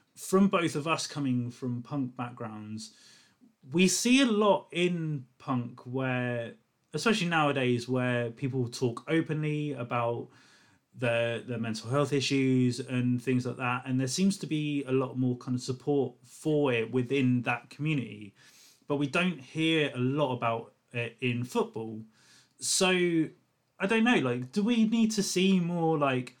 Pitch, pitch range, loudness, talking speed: 130 Hz, 125-160 Hz, -29 LUFS, 155 wpm